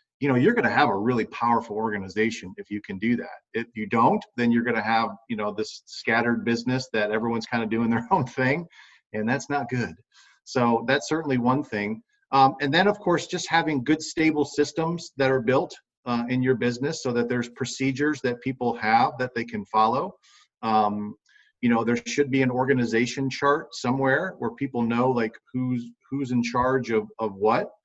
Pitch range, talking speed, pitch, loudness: 115-135 Hz, 205 wpm, 125 Hz, -25 LUFS